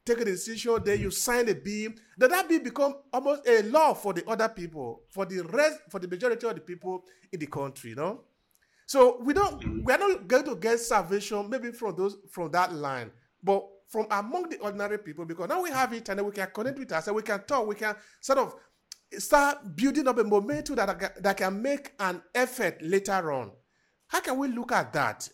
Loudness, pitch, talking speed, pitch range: -28 LUFS, 210 Hz, 225 wpm, 190-255 Hz